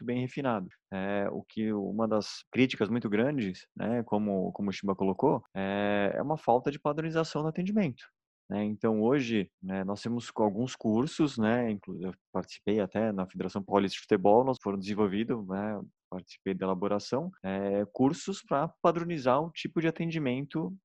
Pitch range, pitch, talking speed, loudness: 100-145 Hz, 110 Hz, 165 wpm, -31 LUFS